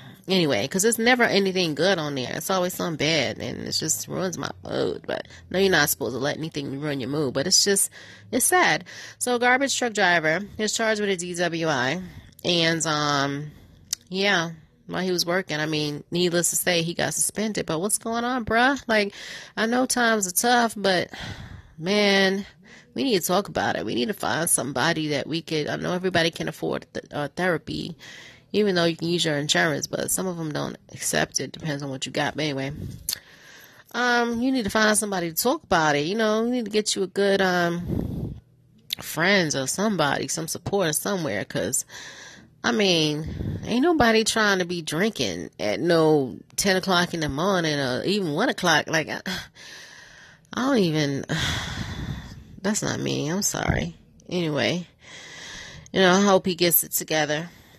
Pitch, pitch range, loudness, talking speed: 175 Hz, 150-205 Hz, -23 LUFS, 185 wpm